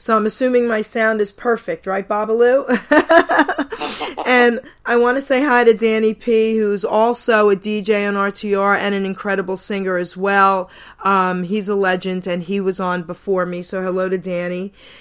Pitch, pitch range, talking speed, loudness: 205 Hz, 190-235 Hz, 175 wpm, -17 LUFS